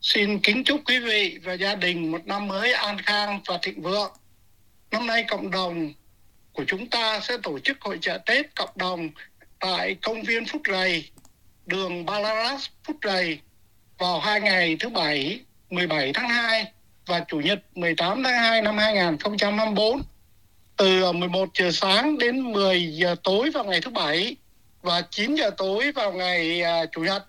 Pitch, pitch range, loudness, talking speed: 195 Hz, 175-220 Hz, -23 LUFS, 165 wpm